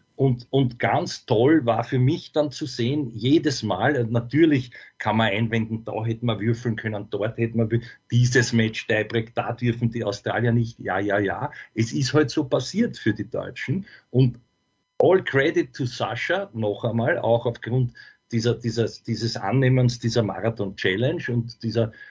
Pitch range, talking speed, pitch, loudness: 115-130 Hz, 170 wpm, 120 Hz, -23 LUFS